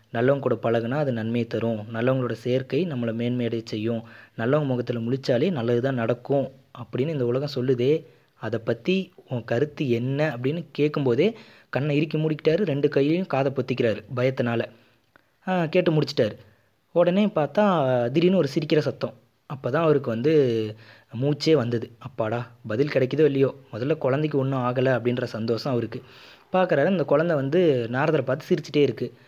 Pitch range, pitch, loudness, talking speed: 120-150 Hz, 130 Hz, -24 LUFS, 140 wpm